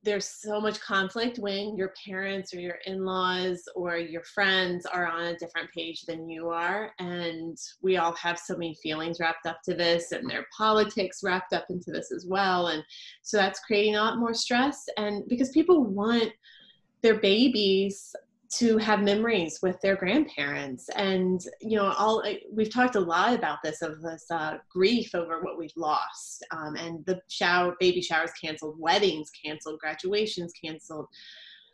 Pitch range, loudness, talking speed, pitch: 170-210 Hz, -28 LUFS, 170 wpm, 185 Hz